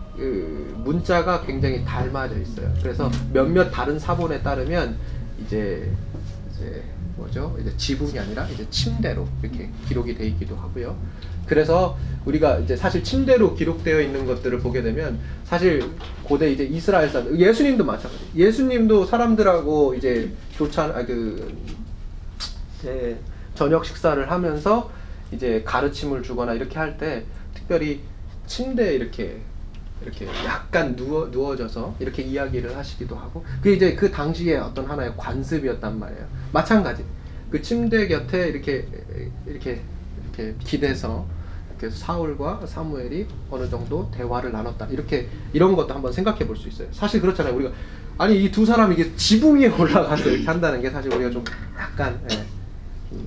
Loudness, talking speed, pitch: -22 LUFS, 335 characters per minute, 125 Hz